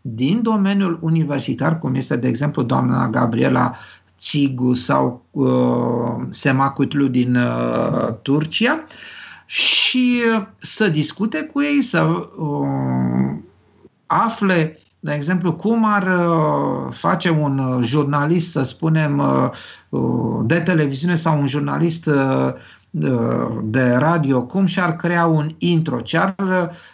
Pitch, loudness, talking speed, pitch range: 150 Hz, -18 LUFS, 120 wpm, 125-175 Hz